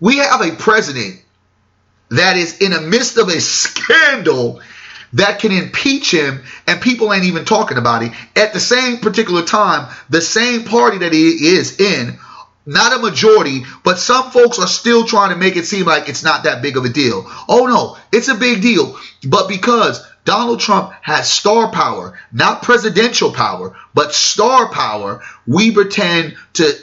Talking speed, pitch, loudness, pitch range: 175 wpm, 205 Hz, -13 LUFS, 160-235 Hz